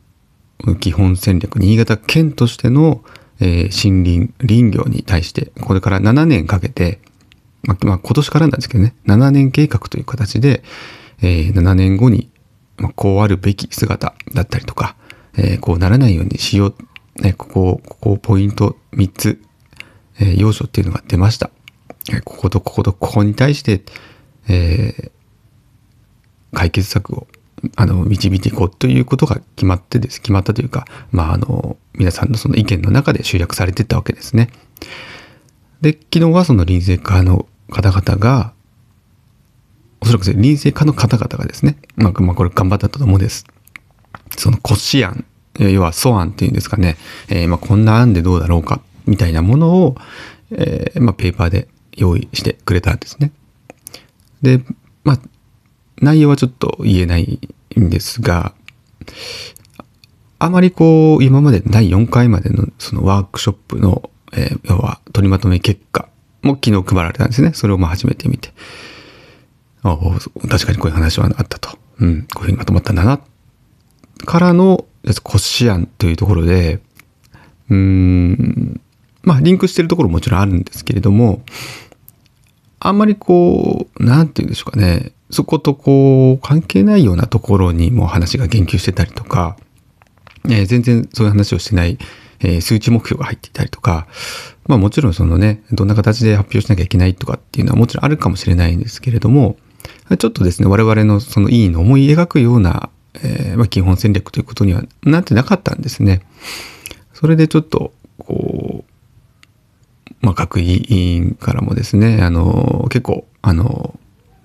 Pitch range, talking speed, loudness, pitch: 95-125 Hz, 325 characters per minute, -14 LUFS, 110 Hz